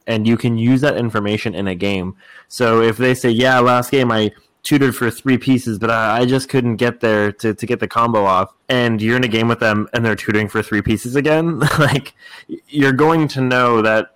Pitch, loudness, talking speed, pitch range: 120 Hz, -16 LUFS, 225 wpm, 110-130 Hz